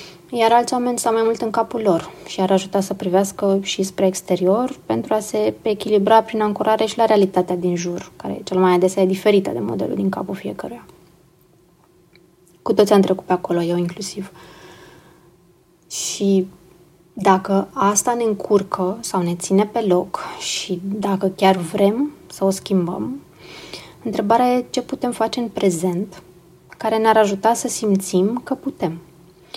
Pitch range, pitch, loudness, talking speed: 180-220 Hz, 195 Hz, -19 LUFS, 160 wpm